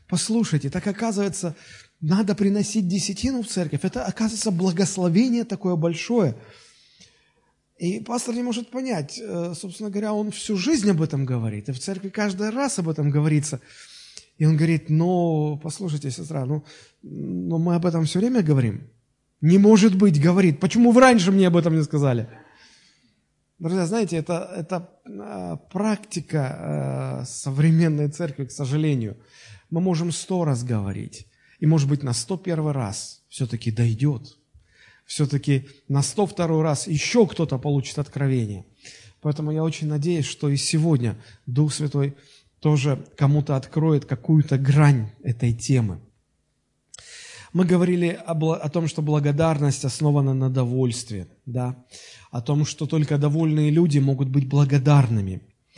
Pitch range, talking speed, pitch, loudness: 135-180 Hz, 135 wpm, 155 Hz, -22 LUFS